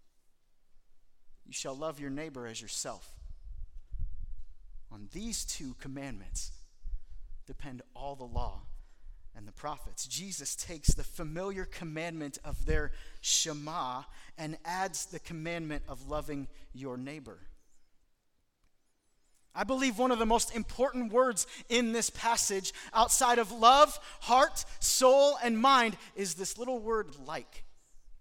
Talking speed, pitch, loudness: 120 wpm, 150 Hz, -31 LUFS